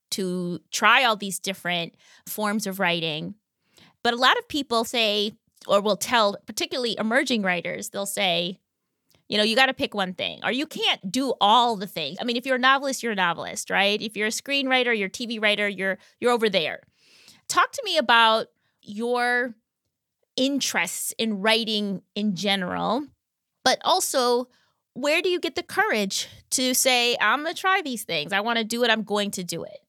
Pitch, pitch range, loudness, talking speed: 225 Hz, 200-260 Hz, -23 LUFS, 190 wpm